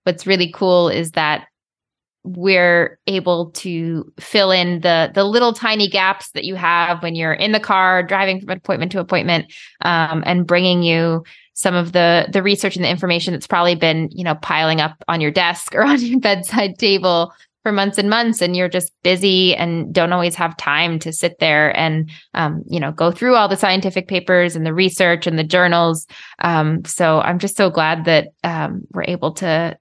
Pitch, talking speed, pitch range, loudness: 175 Hz, 195 wpm, 165-190 Hz, -16 LUFS